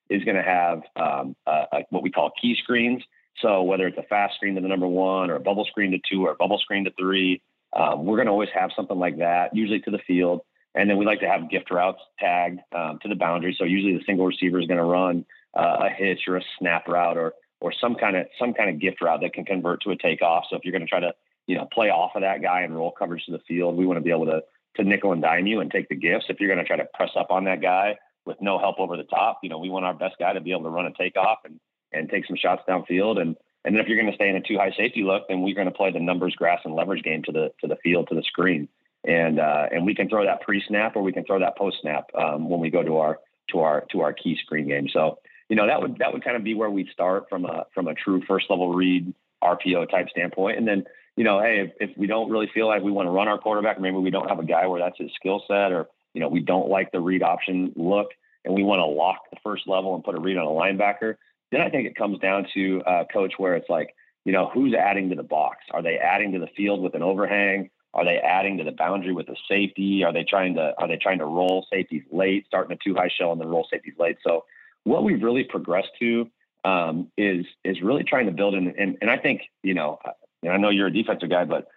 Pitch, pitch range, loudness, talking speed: 95 Hz, 90-100 Hz, -24 LUFS, 285 wpm